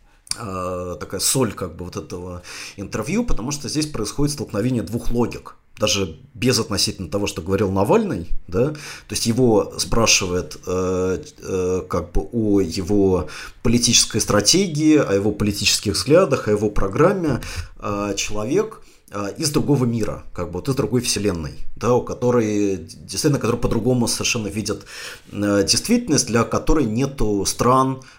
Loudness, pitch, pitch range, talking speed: -20 LUFS, 105 Hz, 95-125 Hz, 130 wpm